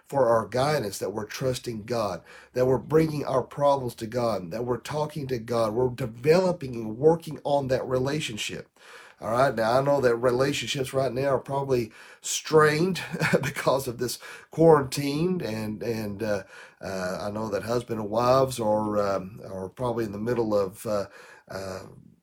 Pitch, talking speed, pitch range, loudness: 125 Hz, 165 wpm, 110-140 Hz, -26 LUFS